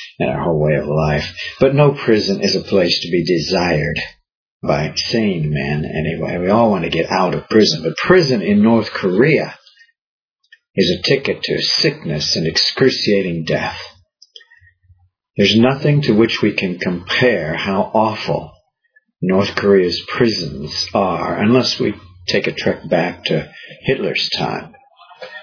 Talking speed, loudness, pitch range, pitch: 145 wpm, -16 LUFS, 90-150 Hz, 115 Hz